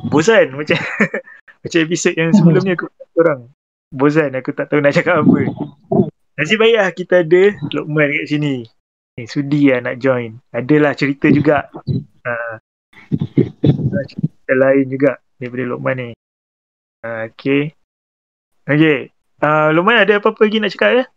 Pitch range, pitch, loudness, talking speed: 120-165 Hz, 145 Hz, -15 LUFS, 145 wpm